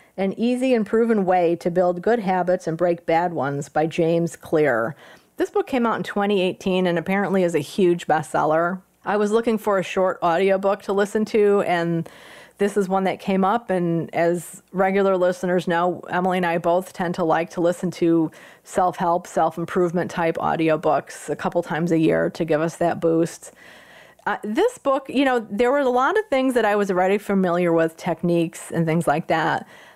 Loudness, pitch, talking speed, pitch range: -21 LUFS, 180 Hz, 195 wpm, 170-200 Hz